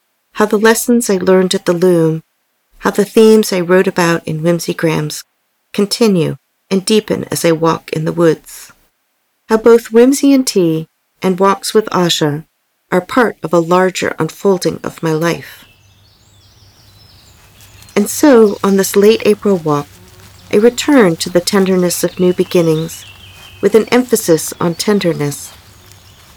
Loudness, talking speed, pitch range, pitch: -12 LUFS, 145 wpm, 150-205 Hz, 175 Hz